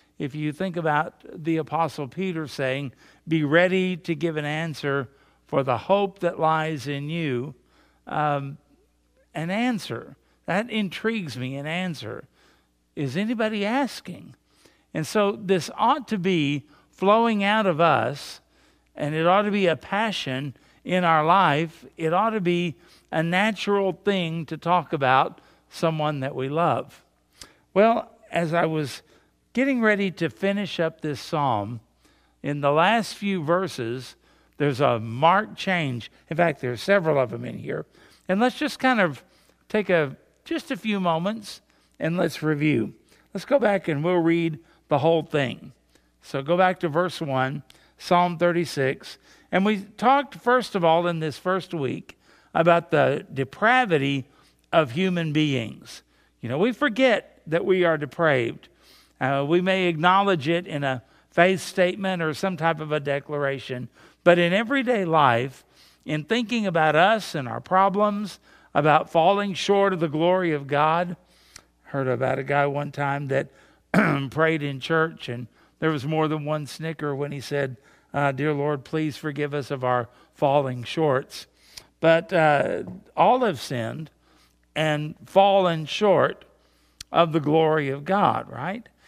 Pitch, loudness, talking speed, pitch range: 160 Hz, -23 LUFS, 155 wpm, 145-190 Hz